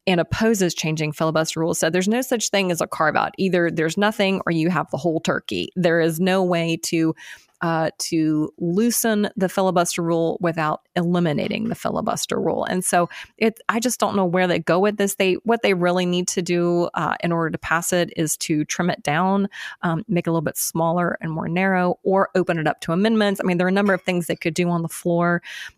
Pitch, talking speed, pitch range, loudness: 175 Hz, 230 wpm, 165-195 Hz, -21 LUFS